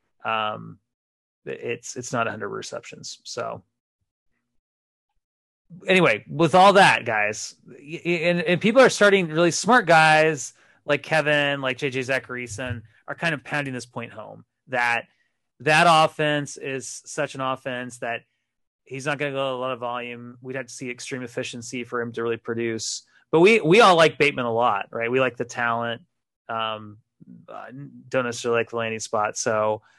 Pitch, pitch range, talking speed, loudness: 125 Hz, 115-145 Hz, 170 wpm, -22 LUFS